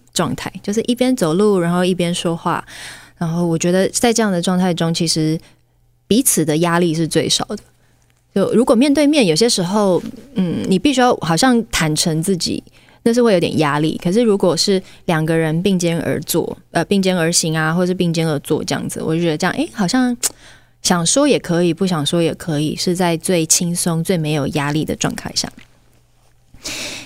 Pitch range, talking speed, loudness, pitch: 165-205 Hz, 280 characters per minute, -17 LUFS, 175 Hz